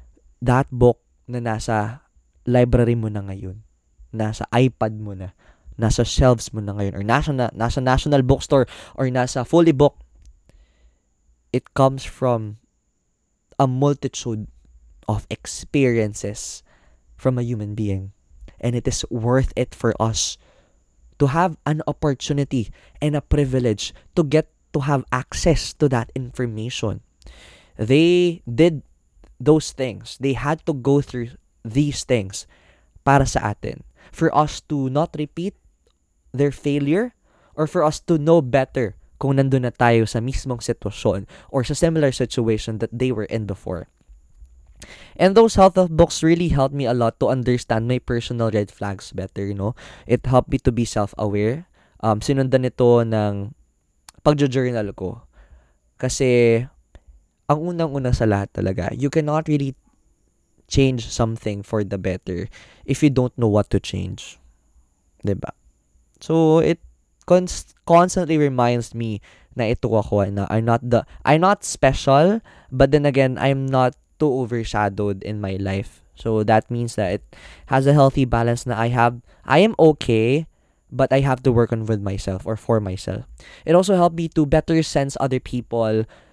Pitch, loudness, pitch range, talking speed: 120 Hz, -20 LUFS, 105-140 Hz, 145 wpm